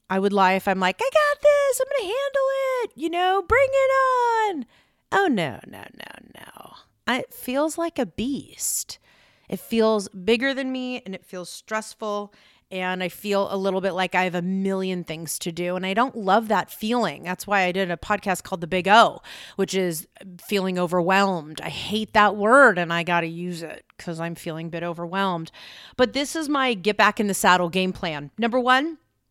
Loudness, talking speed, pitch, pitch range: -22 LUFS, 205 wpm, 200 Hz, 180-260 Hz